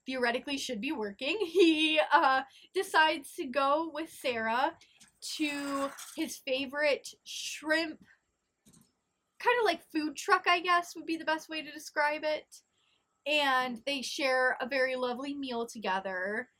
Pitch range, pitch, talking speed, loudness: 260-315 Hz, 290 Hz, 135 wpm, -31 LUFS